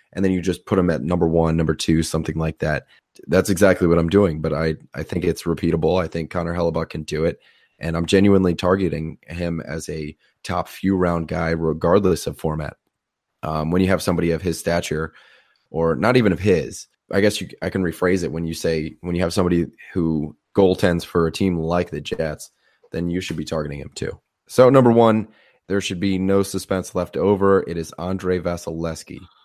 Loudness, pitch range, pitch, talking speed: -21 LUFS, 80-95 Hz, 85 Hz, 210 wpm